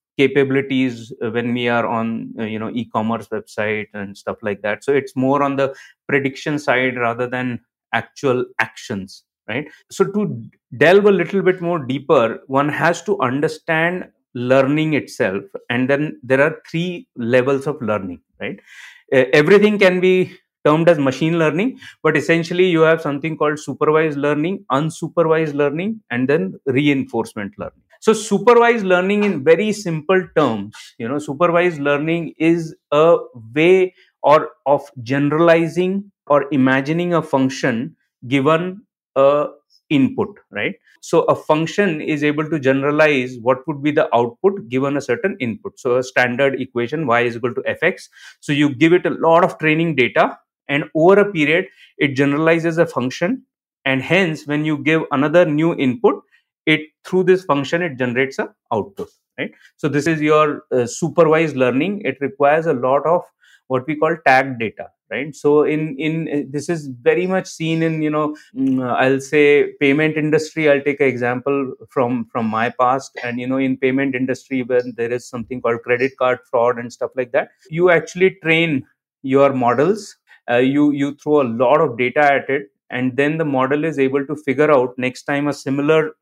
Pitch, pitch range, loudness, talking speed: 145 Hz, 130-165 Hz, -18 LUFS, 170 wpm